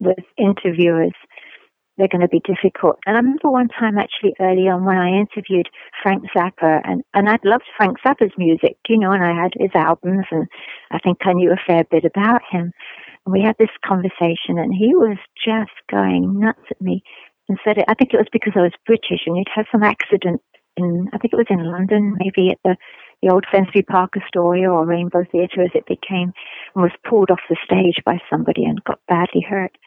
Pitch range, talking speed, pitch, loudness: 175-210 Hz, 215 wpm, 190 Hz, -17 LUFS